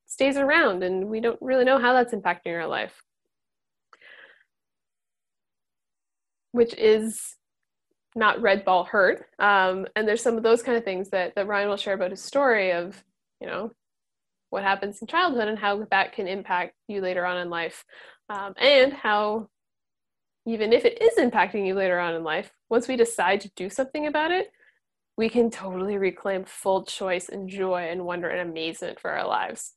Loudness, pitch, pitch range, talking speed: -24 LUFS, 200 Hz, 185-235 Hz, 175 wpm